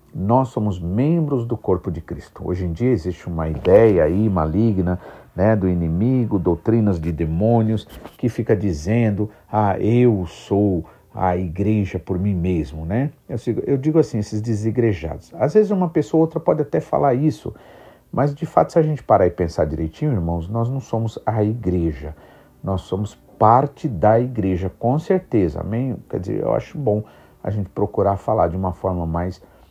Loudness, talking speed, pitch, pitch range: -20 LUFS, 175 wpm, 105 Hz, 90-120 Hz